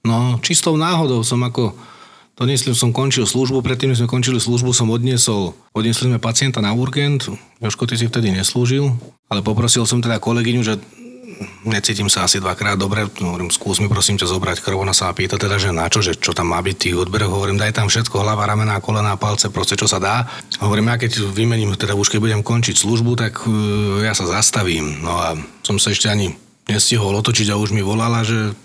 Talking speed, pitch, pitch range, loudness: 200 wpm, 110 Hz, 100-120 Hz, -17 LUFS